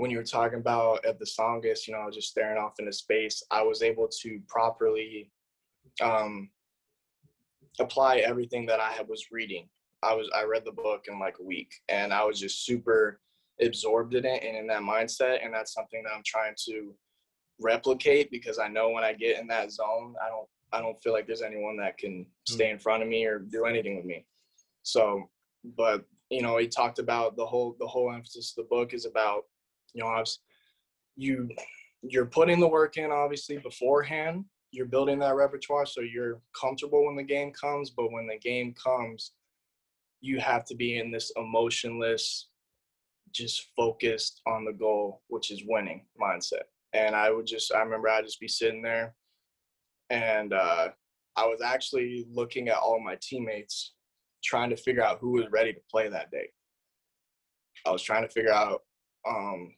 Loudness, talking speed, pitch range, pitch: -29 LUFS, 190 wpm, 110-140 Hz, 115 Hz